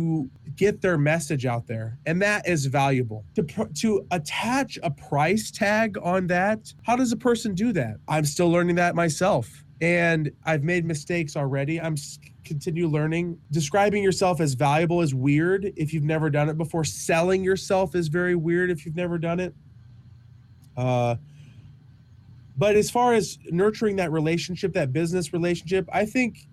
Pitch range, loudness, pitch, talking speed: 145-185 Hz, -24 LUFS, 165 Hz, 165 wpm